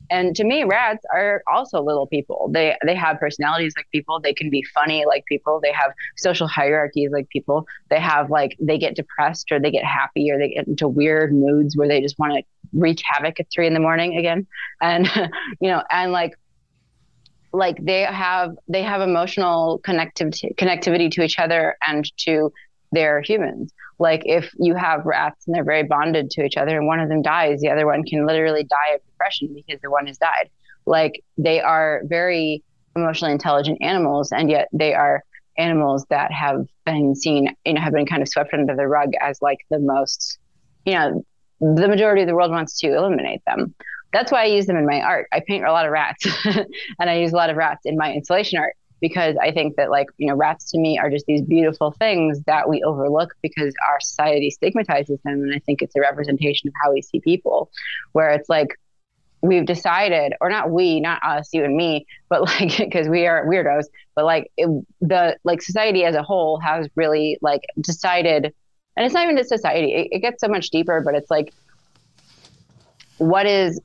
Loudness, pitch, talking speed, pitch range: -19 LUFS, 155 Hz, 205 wpm, 145-170 Hz